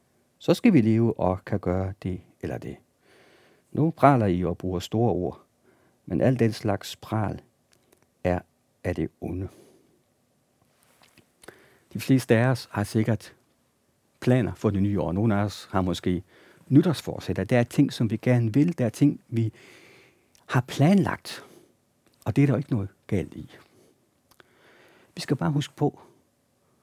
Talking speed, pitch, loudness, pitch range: 155 wpm, 110 Hz, -25 LUFS, 95-130 Hz